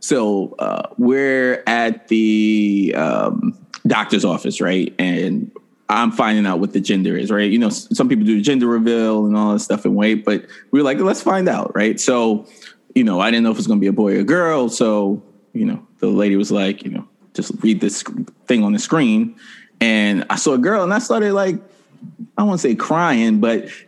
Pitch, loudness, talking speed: 120 Hz, -17 LUFS, 225 wpm